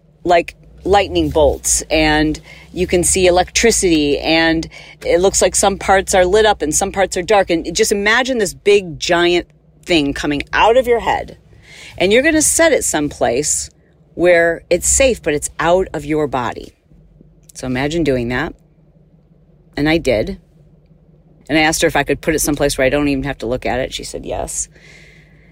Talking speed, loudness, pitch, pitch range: 185 wpm, -15 LUFS, 165 Hz, 155-180 Hz